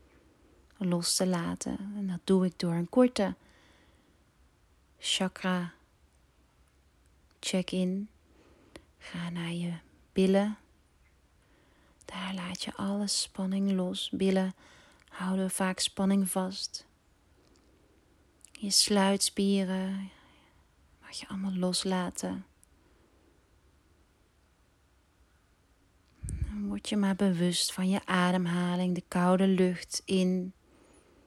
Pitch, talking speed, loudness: 180 Hz, 85 wpm, -30 LUFS